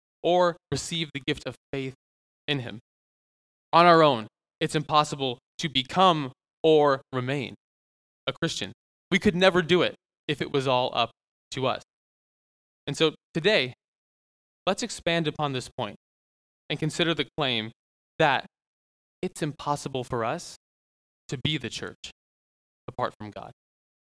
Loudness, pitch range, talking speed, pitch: -26 LUFS, 110-160 Hz, 135 wpm, 140 Hz